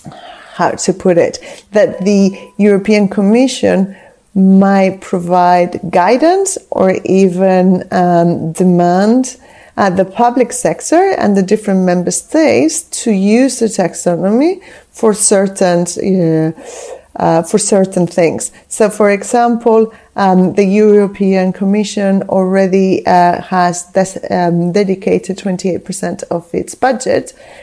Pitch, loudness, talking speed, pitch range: 195 Hz, -12 LUFS, 120 wpm, 185-225 Hz